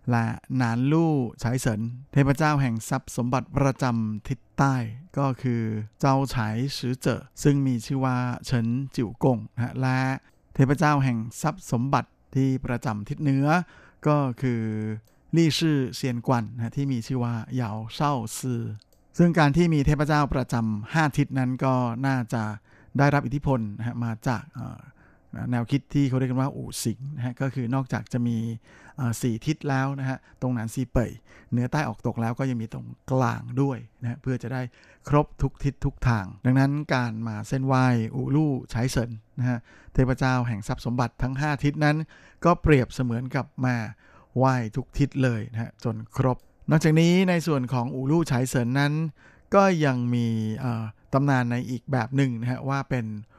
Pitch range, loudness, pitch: 120-140 Hz, -26 LUFS, 130 Hz